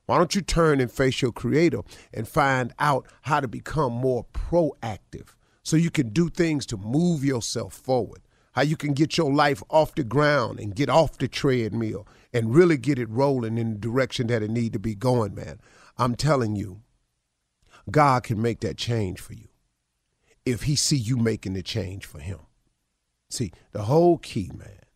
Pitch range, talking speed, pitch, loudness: 110-145 Hz, 190 wpm, 120 Hz, -24 LUFS